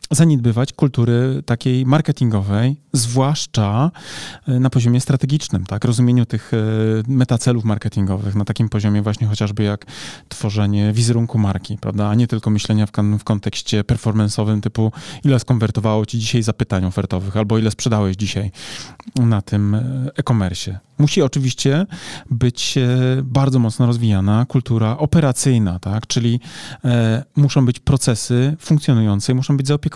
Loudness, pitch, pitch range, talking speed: -18 LUFS, 120 Hz, 105-135 Hz, 125 wpm